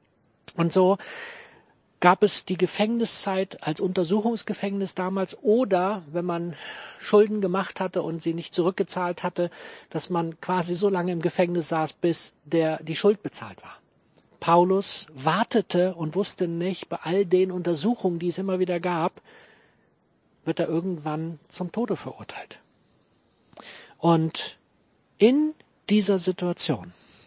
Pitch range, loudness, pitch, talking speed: 165-195 Hz, -25 LUFS, 180 Hz, 130 wpm